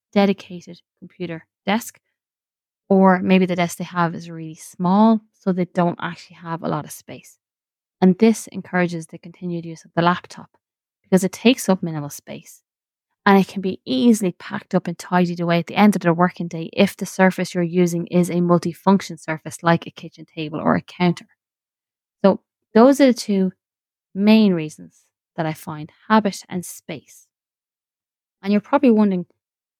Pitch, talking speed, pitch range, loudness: 180 Hz, 175 wpm, 170-200 Hz, -19 LUFS